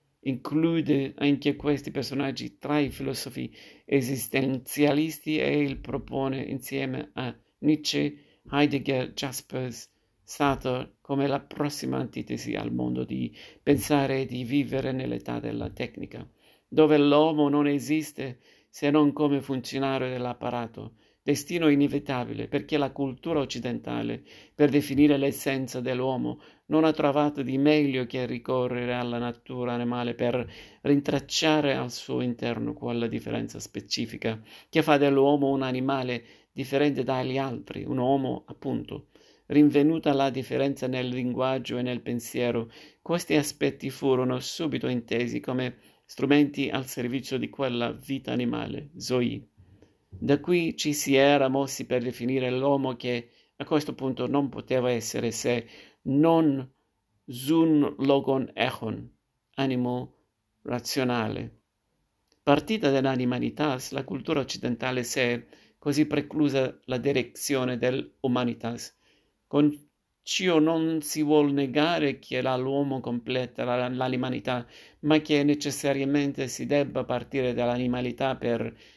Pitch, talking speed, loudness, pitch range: 135 Hz, 115 wpm, -27 LUFS, 125-145 Hz